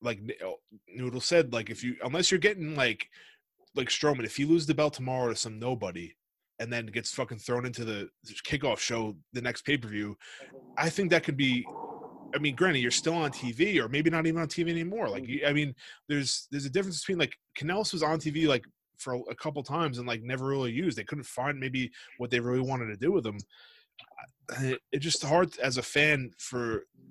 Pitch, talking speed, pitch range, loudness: 135 Hz, 210 wpm, 125-160 Hz, -30 LUFS